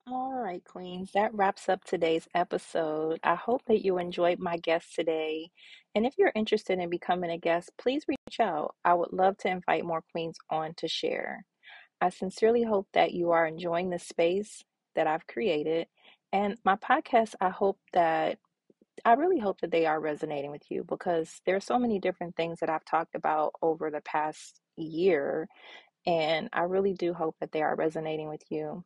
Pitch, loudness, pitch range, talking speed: 175 Hz, -29 LUFS, 160-200 Hz, 185 wpm